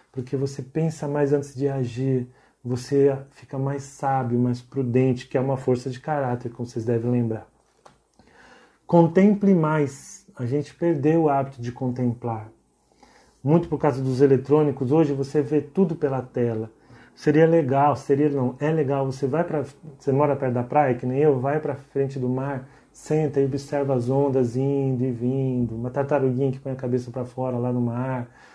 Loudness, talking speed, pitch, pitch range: -23 LUFS, 180 wpm, 135 Hz, 125-145 Hz